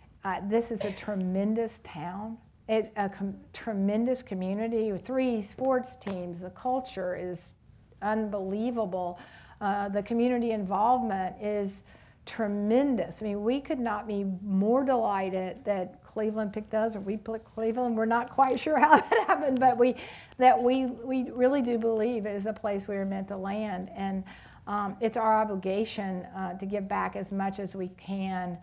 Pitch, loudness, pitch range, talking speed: 210 Hz, -29 LUFS, 195-235 Hz, 165 wpm